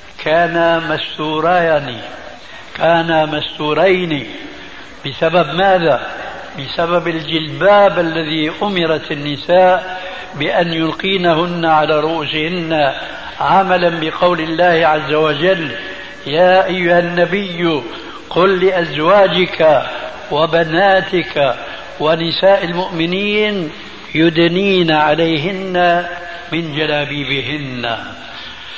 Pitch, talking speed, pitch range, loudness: 170 Hz, 65 wpm, 155-185 Hz, -14 LUFS